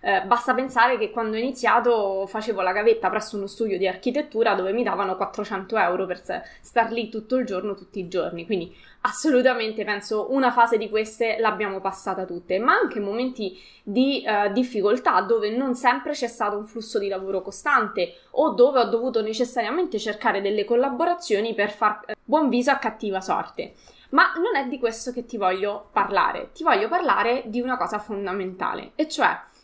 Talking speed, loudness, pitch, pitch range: 180 wpm, -23 LUFS, 220 Hz, 205-250 Hz